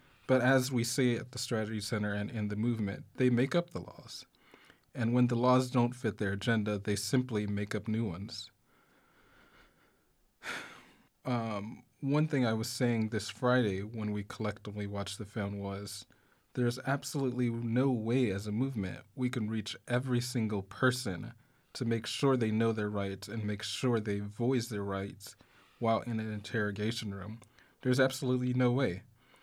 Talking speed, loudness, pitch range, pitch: 165 wpm, -33 LUFS, 105-125 Hz, 115 Hz